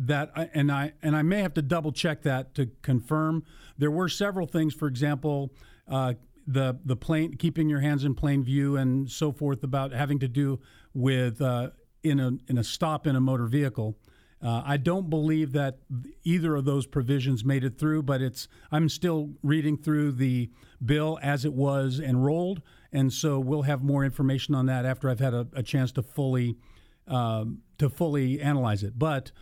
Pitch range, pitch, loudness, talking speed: 130-150 Hz, 140 Hz, -28 LUFS, 190 wpm